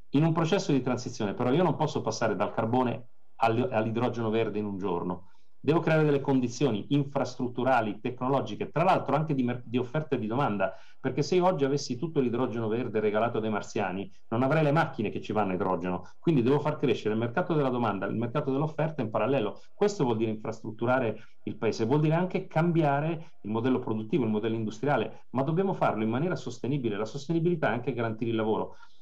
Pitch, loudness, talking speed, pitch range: 125 Hz, -29 LUFS, 195 wpm, 110-145 Hz